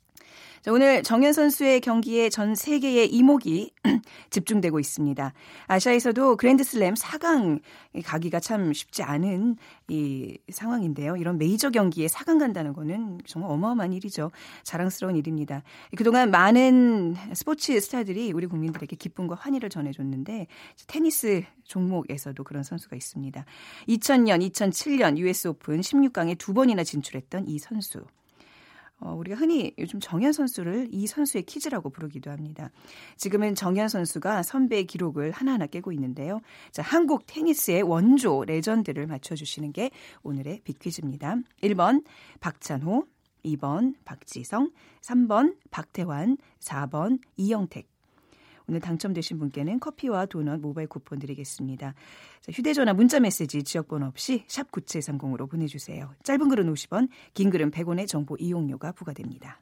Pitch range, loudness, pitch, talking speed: 155-245 Hz, -25 LUFS, 185 Hz, 320 characters per minute